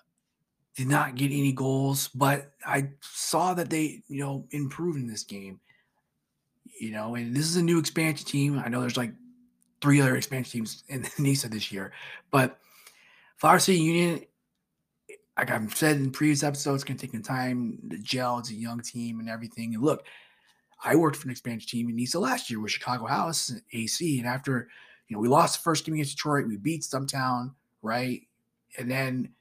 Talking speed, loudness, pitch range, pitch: 190 wpm, -28 LUFS, 120-150 Hz, 135 Hz